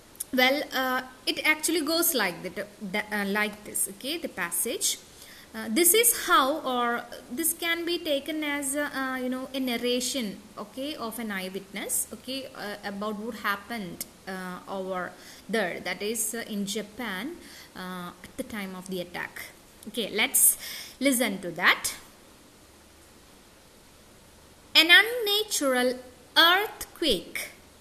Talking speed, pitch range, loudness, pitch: 130 wpm, 205-285 Hz, -26 LUFS, 245 Hz